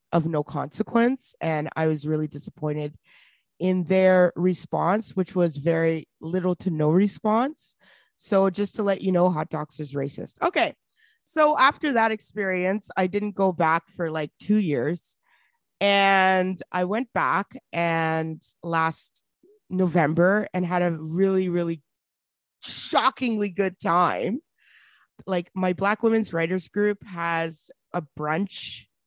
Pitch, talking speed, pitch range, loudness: 185 Hz, 135 wpm, 165-205 Hz, -24 LUFS